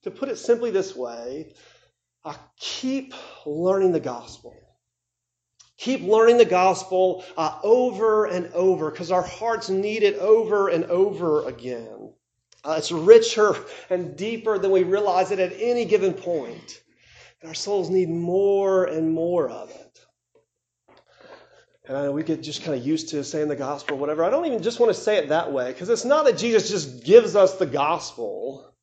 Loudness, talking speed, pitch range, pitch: -22 LUFS, 175 wpm, 160-230 Hz, 190 Hz